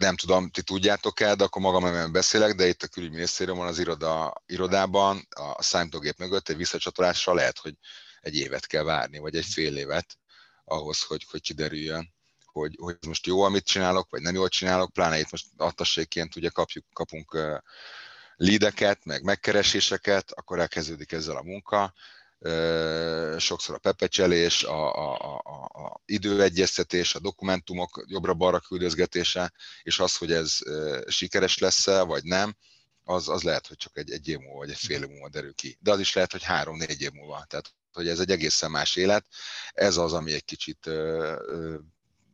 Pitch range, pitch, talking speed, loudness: 80-95 Hz, 90 Hz, 170 wpm, -26 LUFS